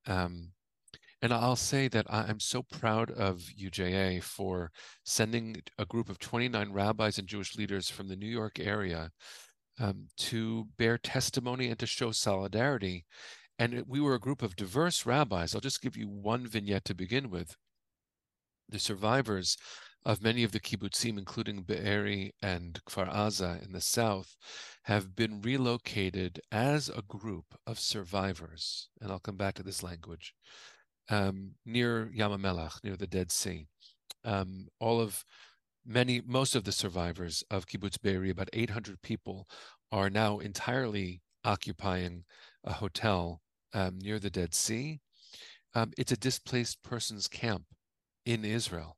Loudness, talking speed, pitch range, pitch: -33 LUFS, 145 wpm, 95-115 Hz, 105 Hz